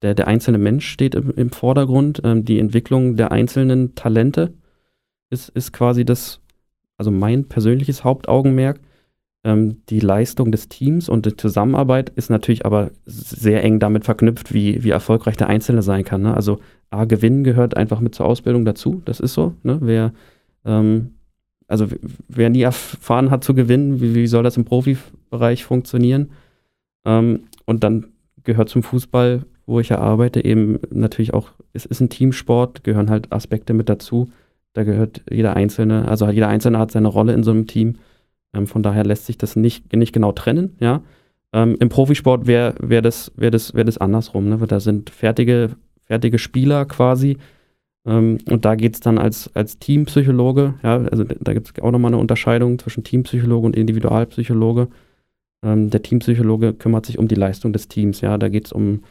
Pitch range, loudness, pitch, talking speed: 110-125 Hz, -17 LUFS, 115 Hz, 180 wpm